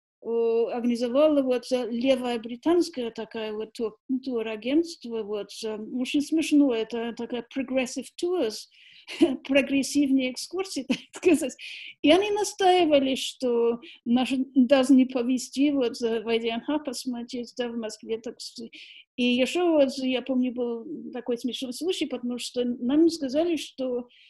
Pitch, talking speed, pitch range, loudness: 255 Hz, 120 wpm, 235-285 Hz, -26 LUFS